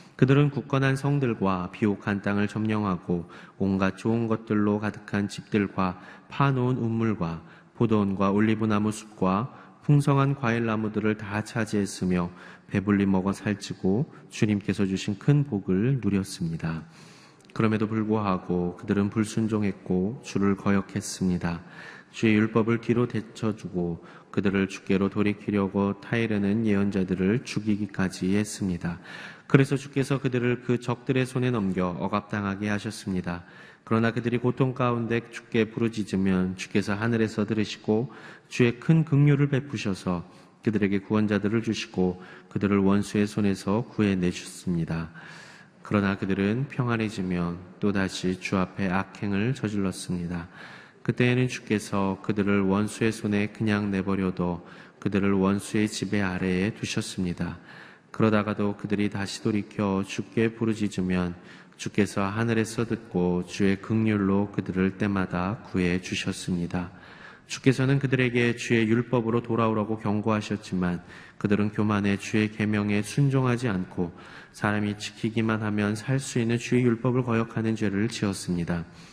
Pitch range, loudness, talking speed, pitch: 95-115 Hz, -26 LUFS, 320 characters per minute, 105 Hz